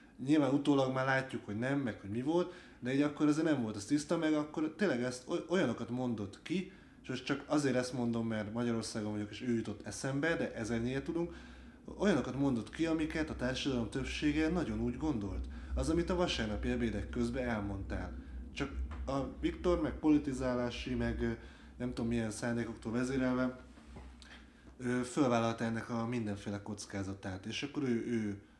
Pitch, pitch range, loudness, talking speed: 125 Hz, 110-145 Hz, -36 LUFS, 165 wpm